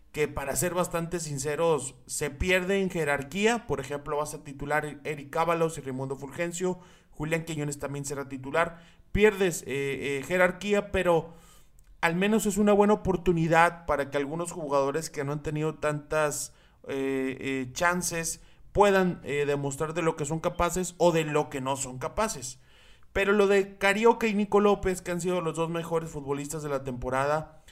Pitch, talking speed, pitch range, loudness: 160 Hz, 170 wpm, 145-180 Hz, -28 LUFS